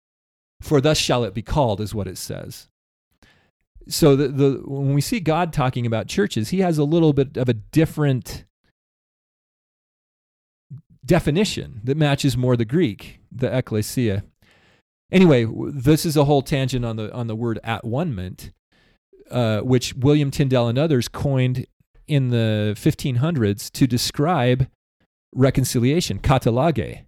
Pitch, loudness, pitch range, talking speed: 130 Hz, -20 LUFS, 110-145 Hz, 135 wpm